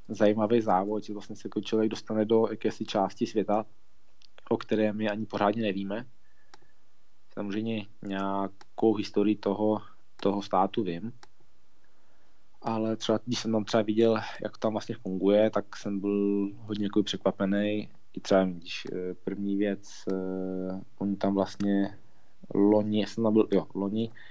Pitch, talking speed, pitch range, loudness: 105 Hz, 140 wpm, 100-110 Hz, -29 LUFS